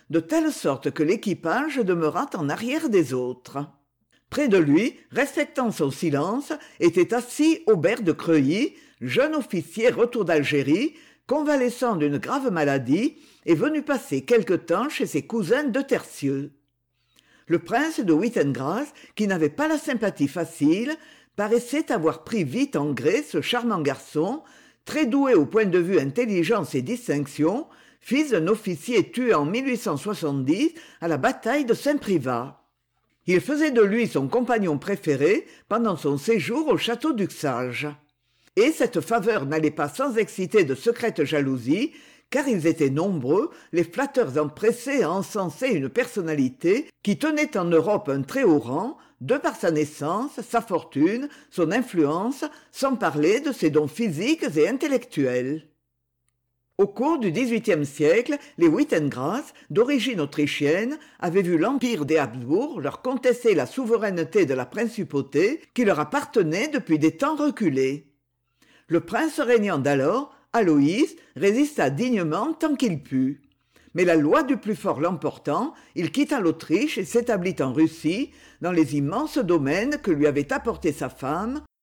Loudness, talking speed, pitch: -24 LUFS, 145 wpm, 210 Hz